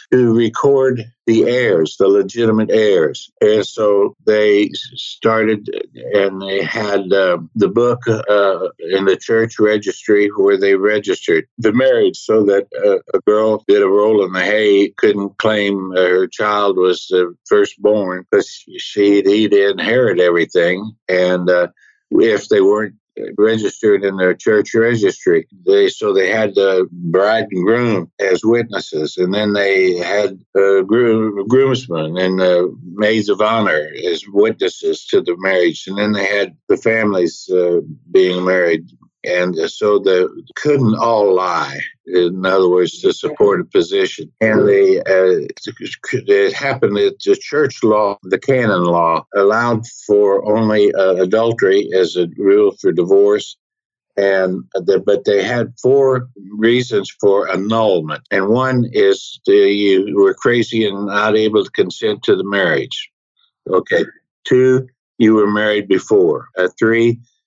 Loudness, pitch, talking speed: -15 LUFS, 120 Hz, 145 wpm